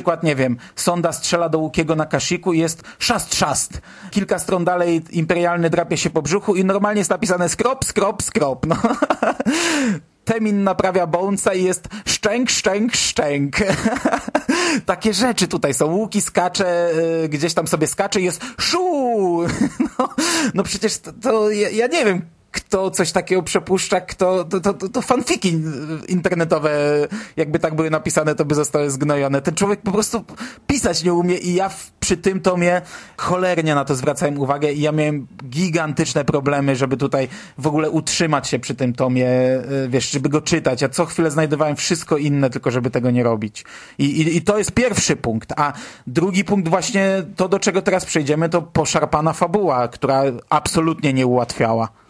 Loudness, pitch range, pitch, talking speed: -19 LUFS, 150-195 Hz, 175 Hz, 170 wpm